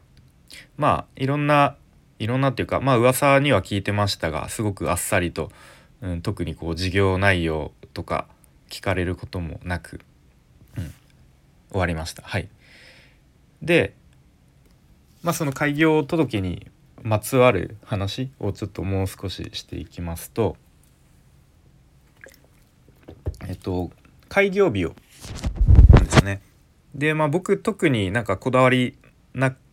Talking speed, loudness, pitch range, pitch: 240 characters per minute, -22 LUFS, 85-130 Hz, 100 Hz